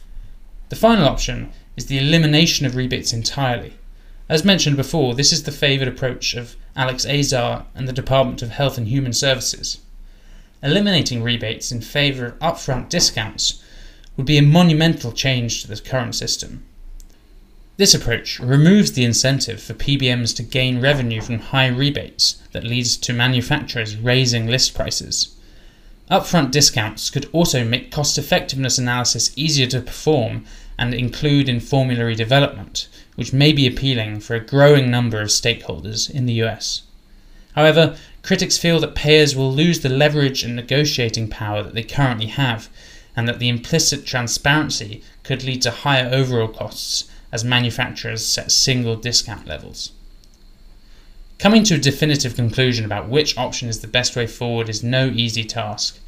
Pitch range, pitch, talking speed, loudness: 115-140 Hz, 125 Hz, 155 wpm, -18 LUFS